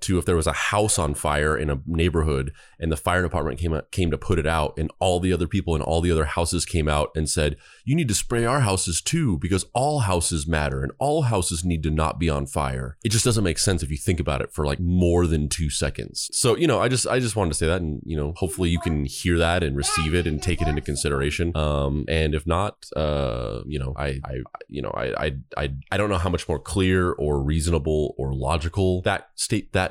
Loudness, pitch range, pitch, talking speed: -23 LUFS, 75-90 Hz, 80 Hz, 255 wpm